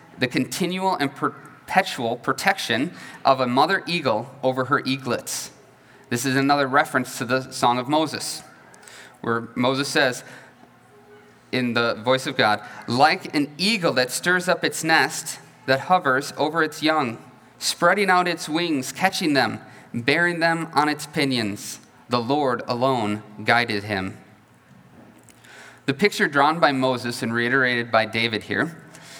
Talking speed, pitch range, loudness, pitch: 140 wpm, 120-155 Hz, -22 LUFS, 135 Hz